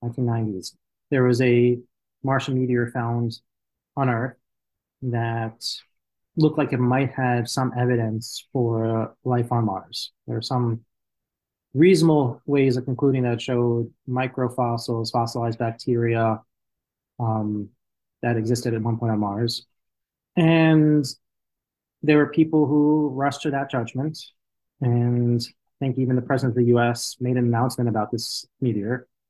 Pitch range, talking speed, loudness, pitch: 115-130 Hz, 135 wpm, -23 LUFS, 120 Hz